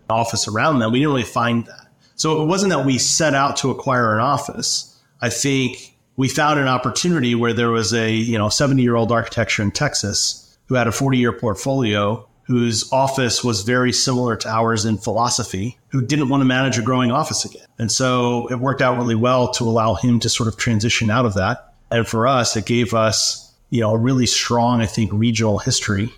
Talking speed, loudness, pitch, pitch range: 215 wpm, -18 LUFS, 120 Hz, 115-130 Hz